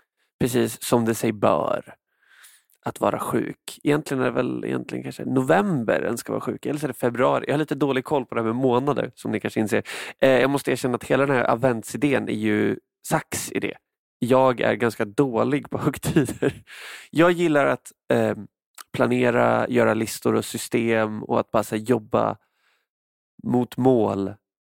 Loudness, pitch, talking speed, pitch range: -23 LUFS, 120 Hz, 175 wpm, 110-135 Hz